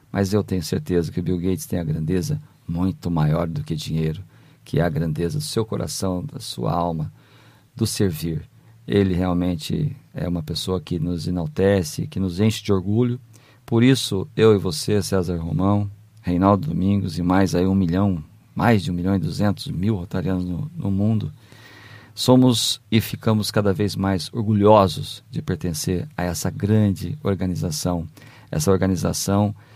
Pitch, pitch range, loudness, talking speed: 100 Hz, 90-110 Hz, -22 LUFS, 165 wpm